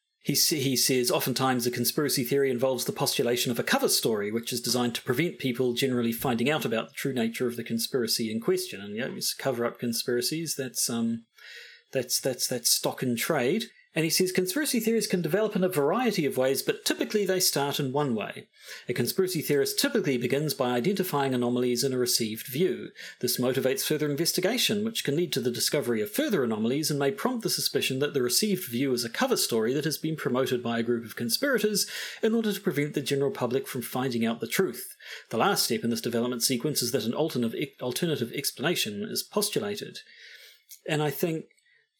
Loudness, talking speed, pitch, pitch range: -27 LUFS, 200 wpm, 140 Hz, 125-185 Hz